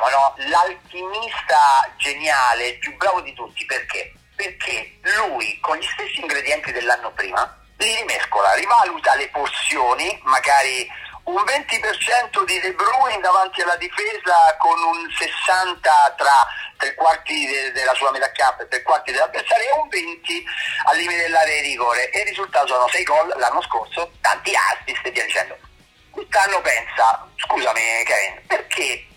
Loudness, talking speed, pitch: -18 LUFS, 145 wpm, 205 Hz